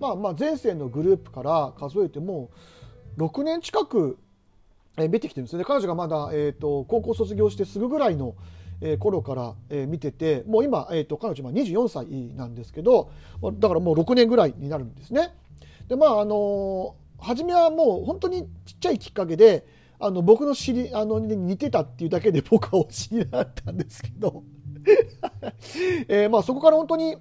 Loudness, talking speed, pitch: -23 LUFS, 320 characters per minute, 180 Hz